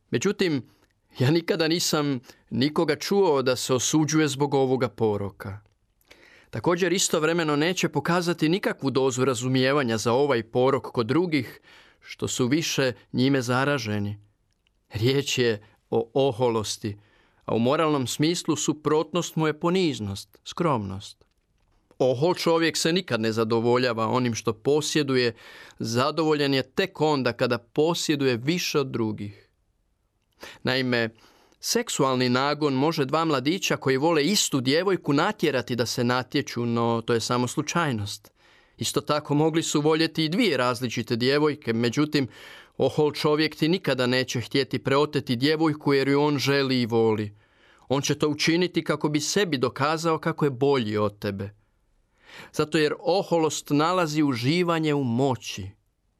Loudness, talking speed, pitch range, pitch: -24 LUFS, 130 wpm, 115-155 Hz, 135 Hz